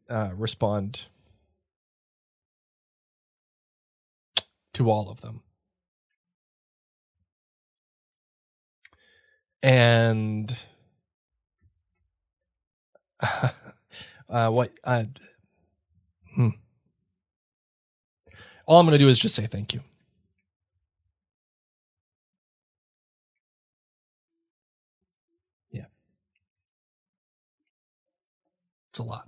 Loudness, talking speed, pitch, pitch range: -23 LUFS, 50 wpm, 100 Hz, 85-120 Hz